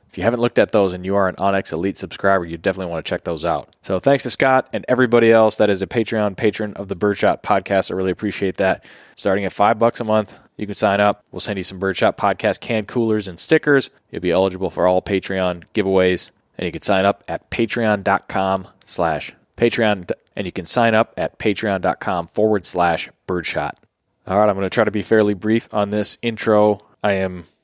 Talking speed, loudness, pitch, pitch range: 220 wpm, -19 LUFS, 100 Hz, 95-110 Hz